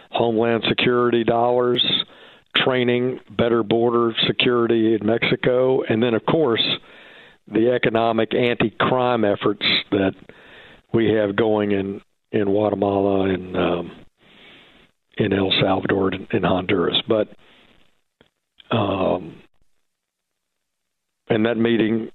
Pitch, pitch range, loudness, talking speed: 115 Hz, 100-120 Hz, -20 LUFS, 100 wpm